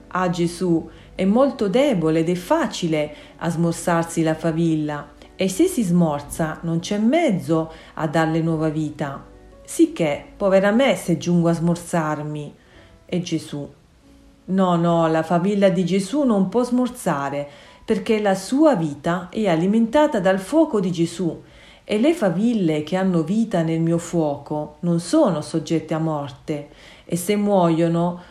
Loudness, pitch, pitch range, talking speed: -21 LUFS, 170 Hz, 160-195 Hz, 145 wpm